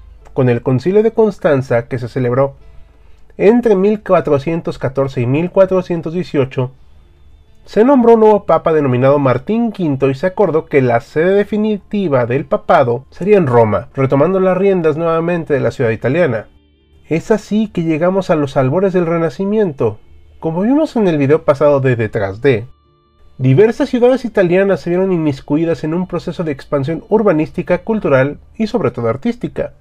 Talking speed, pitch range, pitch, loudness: 150 wpm, 130-195 Hz, 160 Hz, -14 LUFS